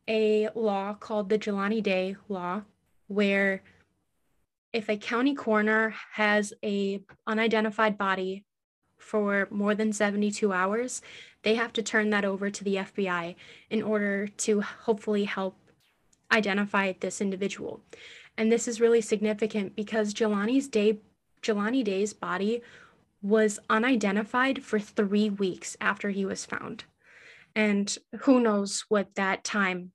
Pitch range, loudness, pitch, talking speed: 200-220 Hz, -28 LUFS, 210 Hz, 130 wpm